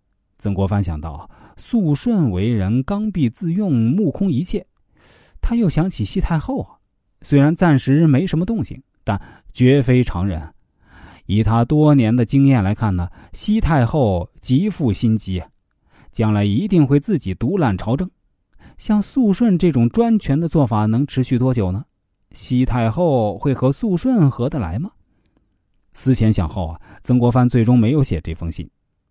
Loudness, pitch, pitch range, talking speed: -18 LUFS, 125 Hz, 100-155 Hz, 225 characters per minute